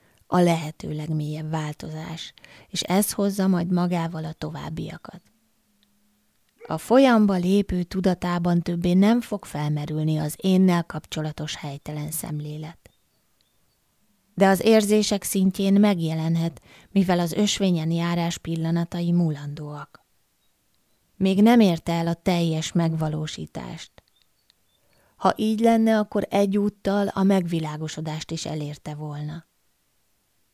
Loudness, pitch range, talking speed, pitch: -23 LUFS, 155-200 Hz, 100 wpm, 175 Hz